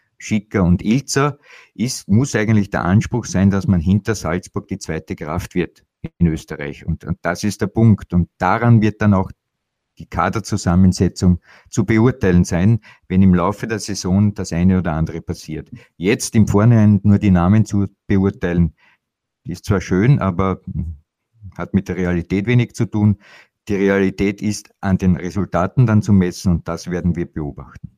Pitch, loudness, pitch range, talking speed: 95 Hz, -18 LUFS, 90-105 Hz, 165 wpm